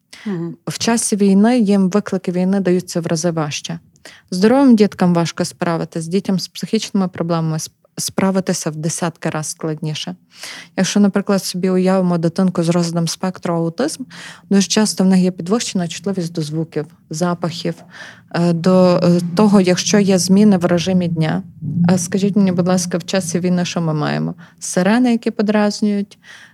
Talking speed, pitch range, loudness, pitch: 145 wpm, 170-200 Hz, -17 LUFS, 180 Hz